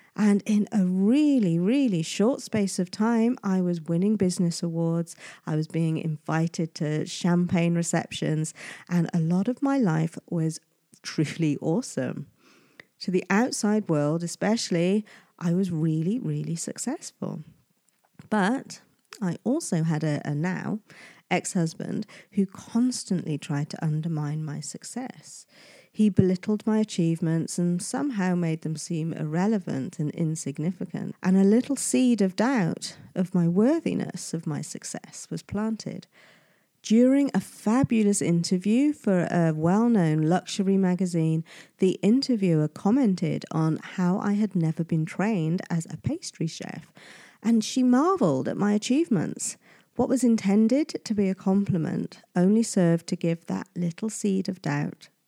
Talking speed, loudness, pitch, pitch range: 140 wpm, -26 LUFS, 185 Hz, 165-215 Hz